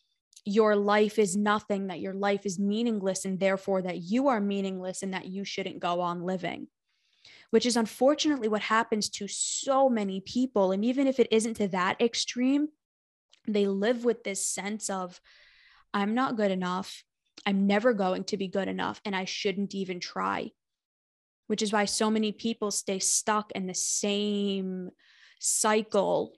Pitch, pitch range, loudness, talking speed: 205 Hz, 190-225 Hz, -28 LUFS, 165 wpm